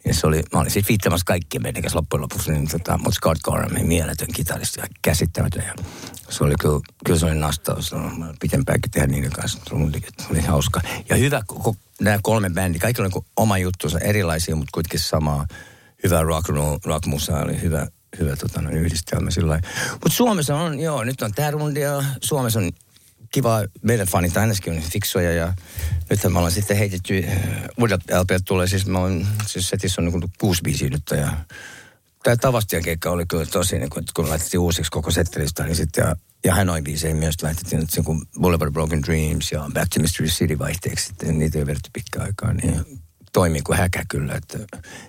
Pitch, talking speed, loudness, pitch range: 90 Hz, 185 wpm, -22 LUFS, 80-105 Hz